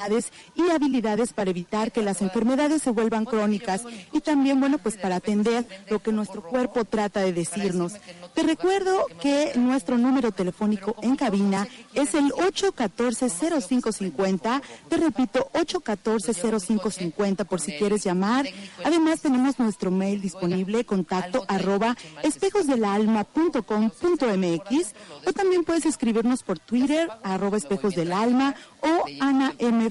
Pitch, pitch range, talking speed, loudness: 230 Hz, 200-275 Hz, 120 wpm, -24 LUFS